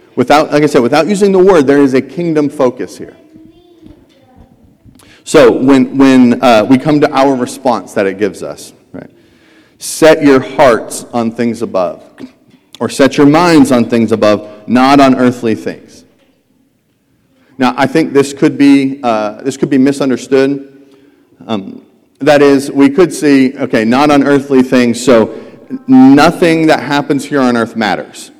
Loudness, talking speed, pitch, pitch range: -9 LUFS, 160 wpm, 140 Hz, 125-150 Hz